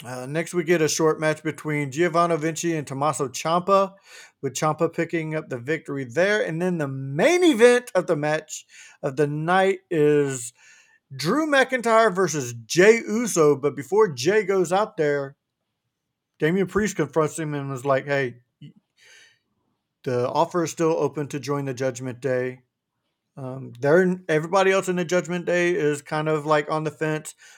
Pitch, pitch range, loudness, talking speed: 155 Hz, 145-180 Hz, -22 LUFS, 165 wpm